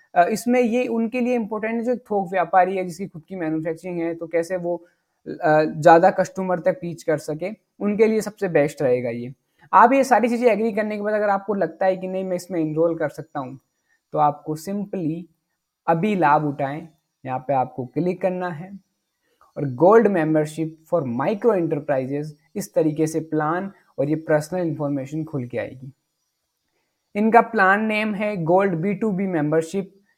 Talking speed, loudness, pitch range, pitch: 175 wpm, -21 LUFS, 155-200 Hz, 175 Hz